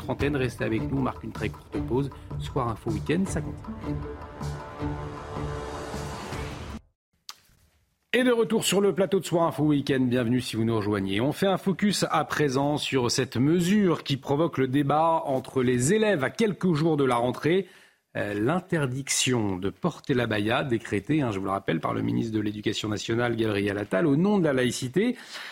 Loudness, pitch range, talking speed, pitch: -26 LUFS, 100-155 Hz, 180 wpm, 125 Hz